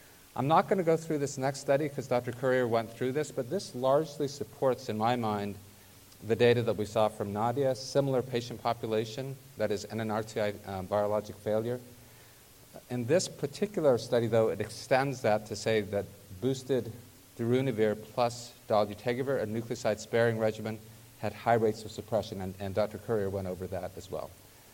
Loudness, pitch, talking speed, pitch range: -31 LUFS, 115 Hz, 170 wpm, 105-130 Hz